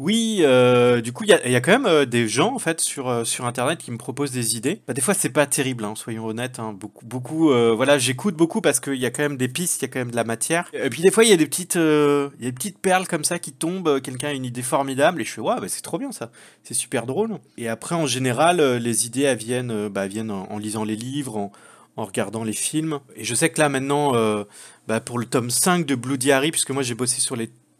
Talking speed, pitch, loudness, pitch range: 280 wpm, 130 Hz, -21 LUFS, 120-150 Hz